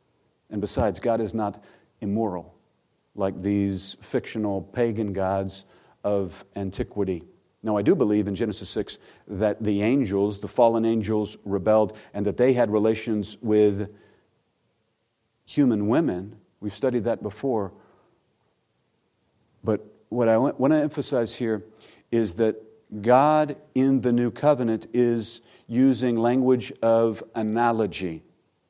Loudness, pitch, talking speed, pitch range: -24 LUFS, 110 Hz, 120 wpm, 100-115 Hz